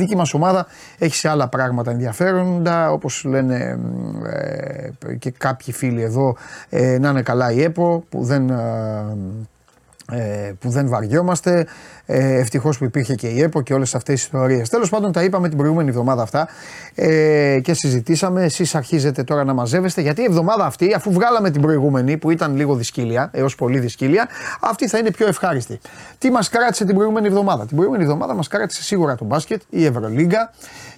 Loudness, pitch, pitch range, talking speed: -18 LUFS, 150 Hz, 130-175 Hz, 175 wpm